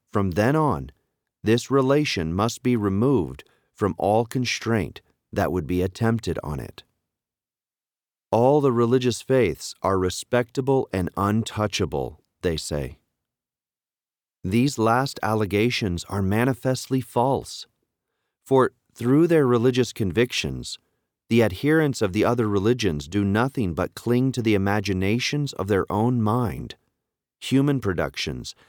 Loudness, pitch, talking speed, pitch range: -23 LUFS, 115 Hz, 120 wpm, 100-130 Hz